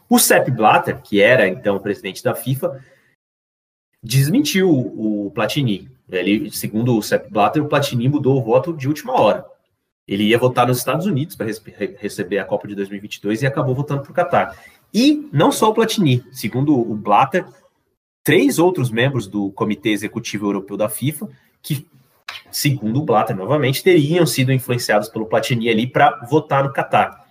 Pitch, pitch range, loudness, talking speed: 130 Hz, 110-150 Hz, -18 LUFS, 165 wpm